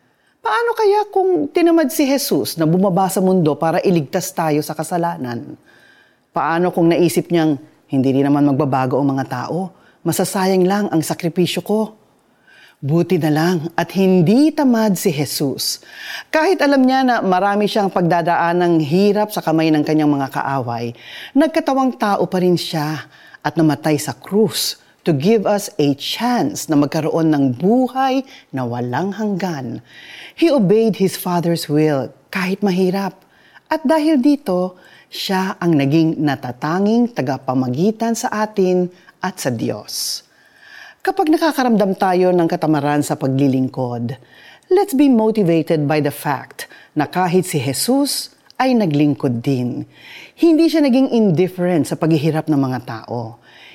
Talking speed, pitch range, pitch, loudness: 140 wpm, 150-215 Hz, 180 Hz, -17 LUFS